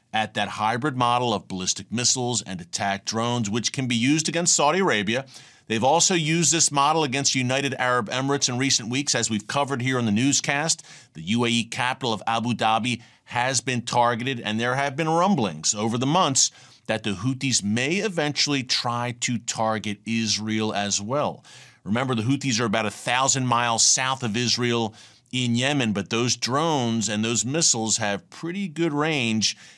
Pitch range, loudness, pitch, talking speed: 110-140 Hz, -23 LUFS, 120 Hz, 175 wpm